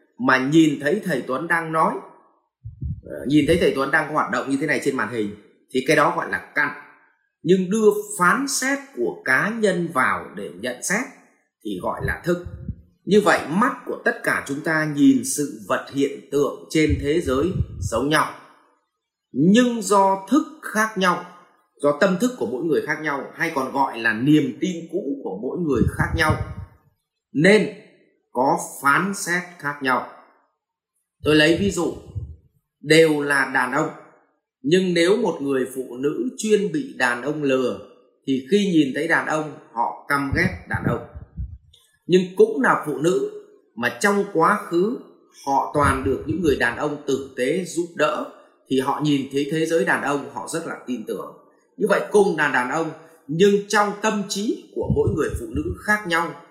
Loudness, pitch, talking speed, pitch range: -21 LUFS, 160 Hz, 180 wpm, 145-200 Hz